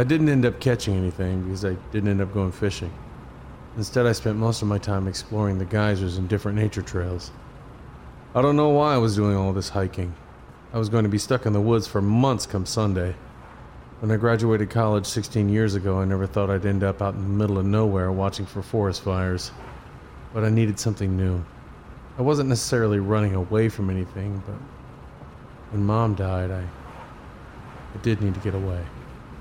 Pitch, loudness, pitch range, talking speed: 100 Hz, -24 LUFS, 95-110 Hz, 195 wpm